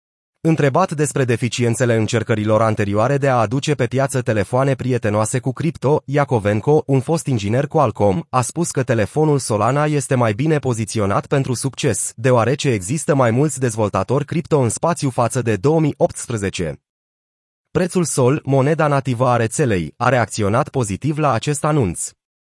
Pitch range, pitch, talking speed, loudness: 115-150 Hz, 130 Hz, 145 wpm, -18 LUFS